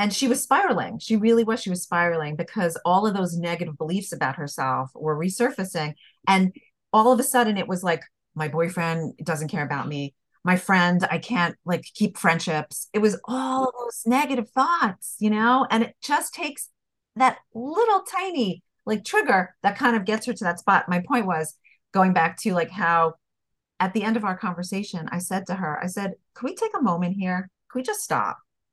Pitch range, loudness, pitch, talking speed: 170-240 Hz, -24 LUFS, 190 Hz, 205 wpm